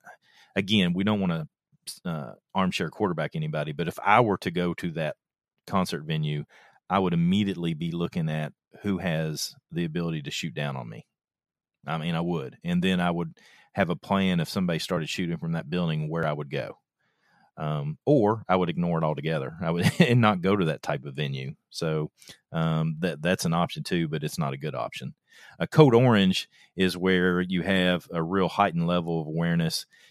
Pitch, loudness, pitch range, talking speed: 85 Hz, -27 LUFS, 80-95 Hz, 195 wpm